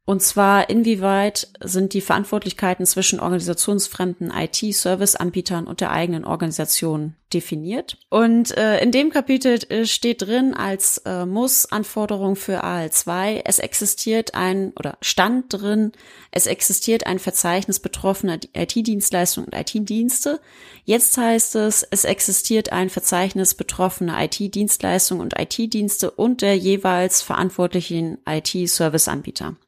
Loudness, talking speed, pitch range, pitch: -19 LUFS, 115 wpm, 180-220 Hz, 195 Hz